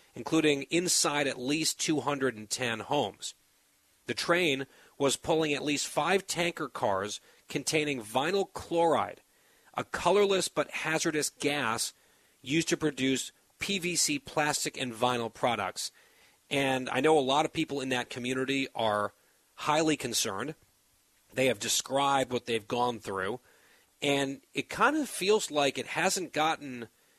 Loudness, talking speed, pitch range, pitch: -30 LUFS, 130 wpm, 130-160 Hz, 145 Hz